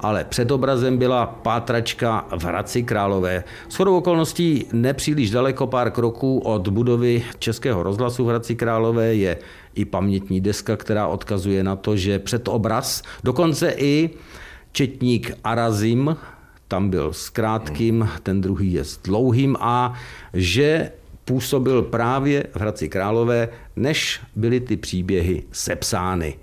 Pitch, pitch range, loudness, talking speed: 115 Hz, 100-125 Hz, -21 LUFS, 130 wpm